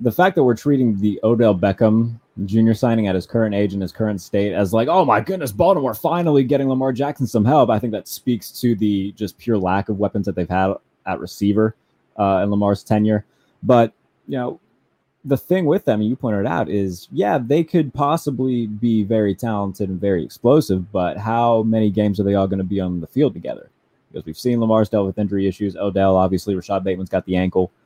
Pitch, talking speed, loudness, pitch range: 105 Hz, 220 wpm, -19 LUFS, 100-115 Hz